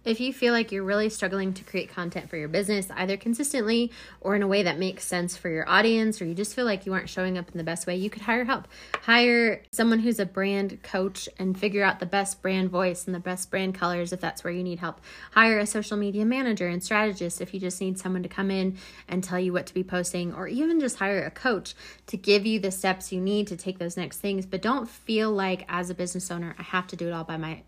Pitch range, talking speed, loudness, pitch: 180-210 Hz, 265 wpm, -27 LUFS, 190 Hz